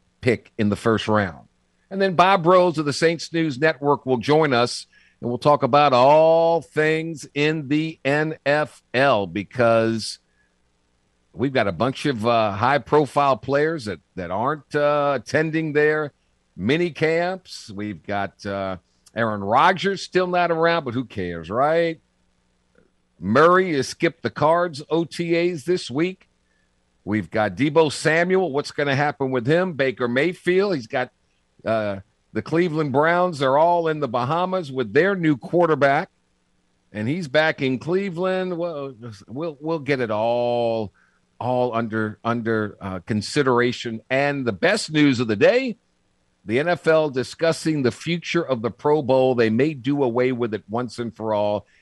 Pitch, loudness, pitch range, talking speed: 135 Hz, -21 LUFS, 110-160 Hz, 155 wpm